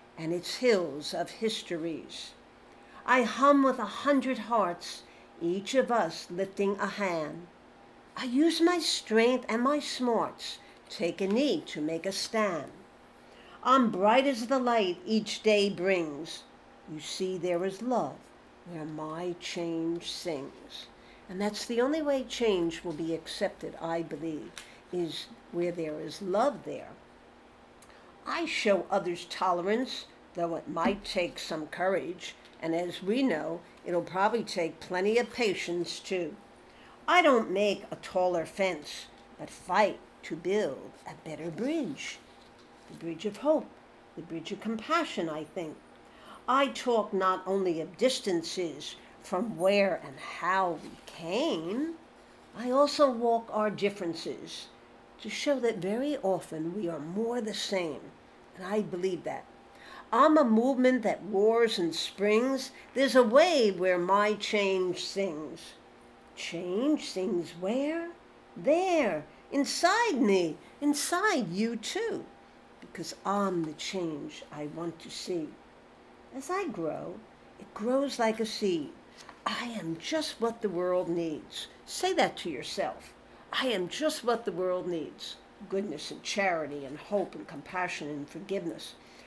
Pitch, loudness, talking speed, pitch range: 195 Hz, -30 LUFS, 140 wpm, 170-245 Hz